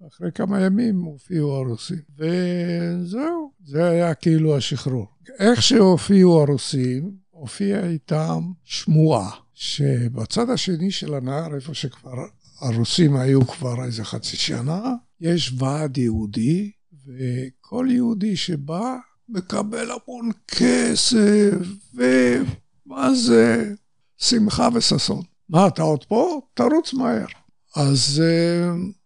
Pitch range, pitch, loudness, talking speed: 135-200 Hz, 170 Hz, -20 LUFS, 100 wpm